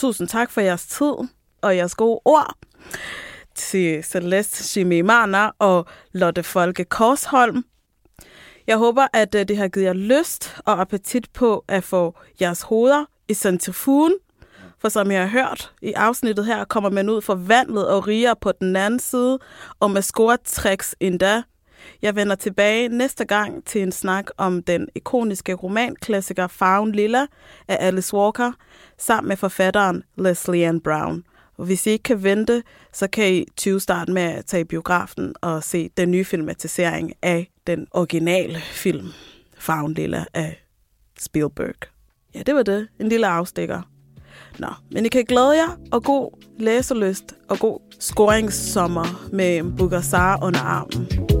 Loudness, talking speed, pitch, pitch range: -20 LUFS, 150 wpm, 200 Hz, 180-230 Hz